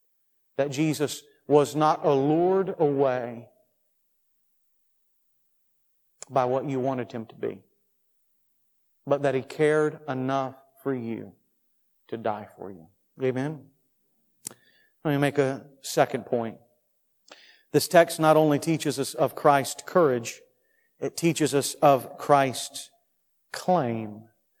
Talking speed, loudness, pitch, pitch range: 110 wpm, -25 LUFS, 140 Hz, 130-150 Hz